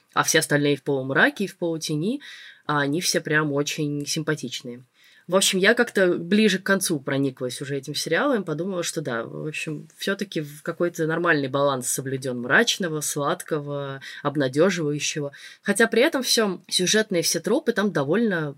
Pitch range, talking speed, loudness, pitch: 145-190 Hz, 155 wpm, -23 LUFS, 160 Hz